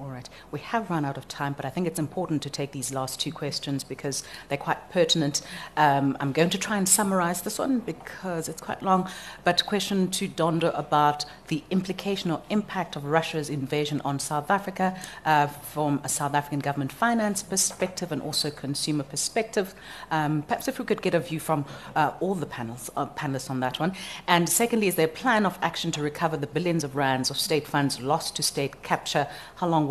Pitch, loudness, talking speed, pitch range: 160 Hz, -27 LUFS, 210 wpm, 145-185 Hz